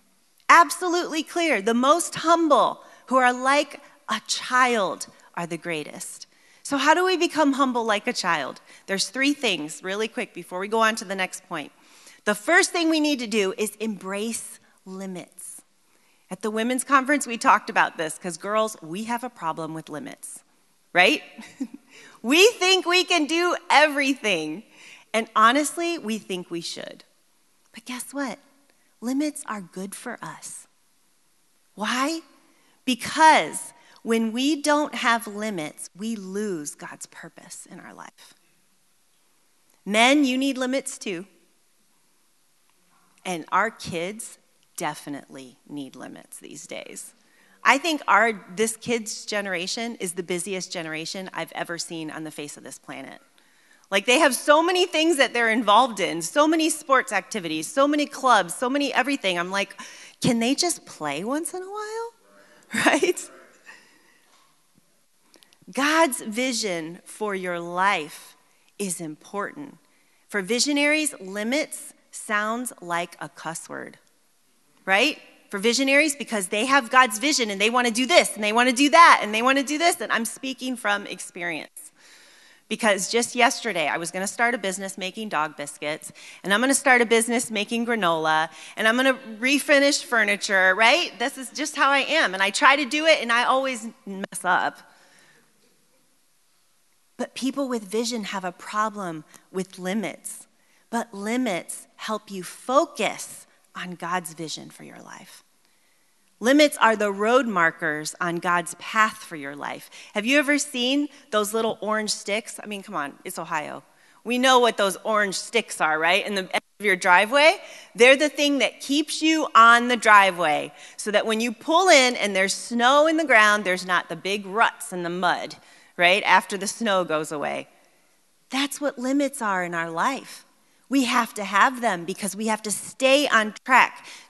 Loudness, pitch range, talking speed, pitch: -22 LUFS, 190-275 Hz, 160 wpm, 225 Hz